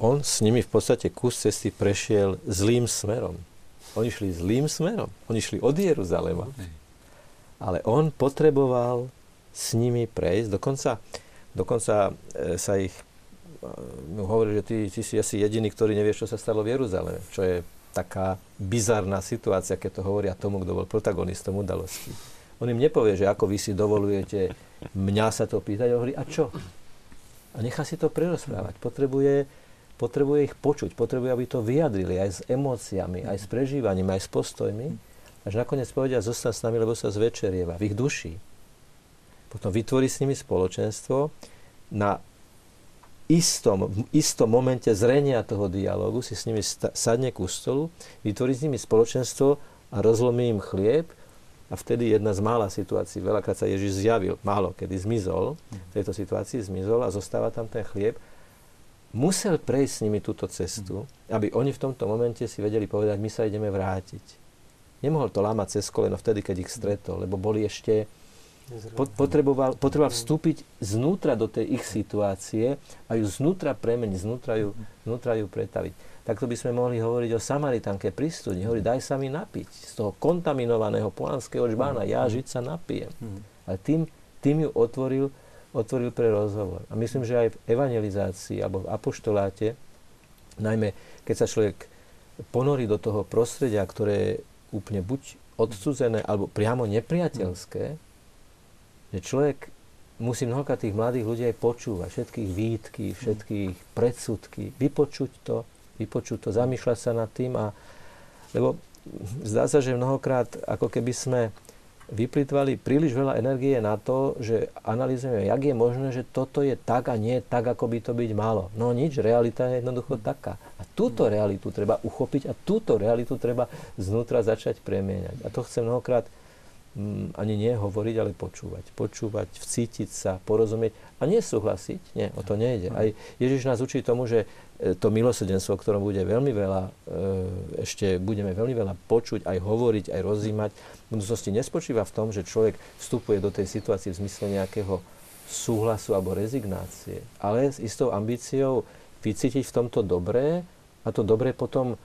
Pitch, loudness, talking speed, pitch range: 115 Hz, -27 LUFS, 155 wpm, 100-125 Hz